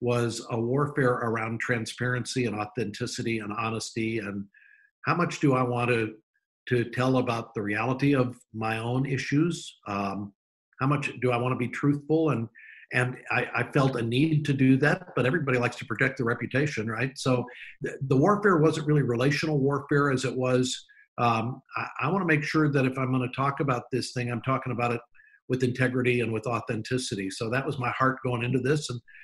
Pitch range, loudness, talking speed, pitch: 120-140 Hz, -27 LUFS, 205 wpm, 125 Hz